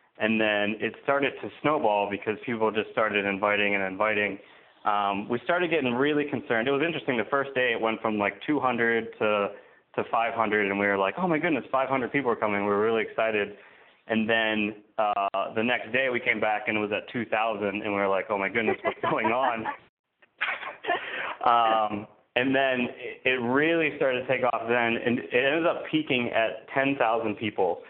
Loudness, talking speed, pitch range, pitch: -26 LUFS, 205 wpm, 105-130 Hz, 110 Hz